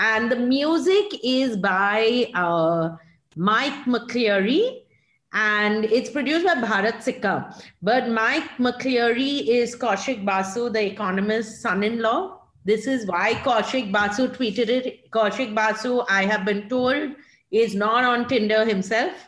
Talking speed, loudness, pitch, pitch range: 135 wpm, -22 LUFS, 230 Hz, 210-255 Hz